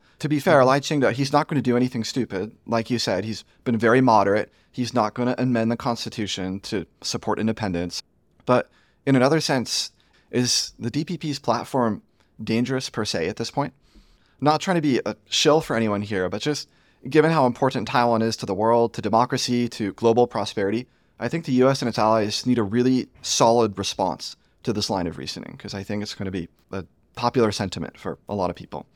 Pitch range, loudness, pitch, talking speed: 105-130 Hz, -23 LUFS, 120 Hz, 205 wpm